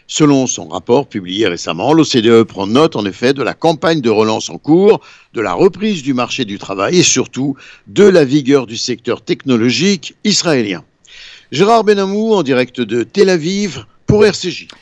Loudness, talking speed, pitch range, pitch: -13 LUFS, 170 wpm, 115-175 Hz, 135 Hz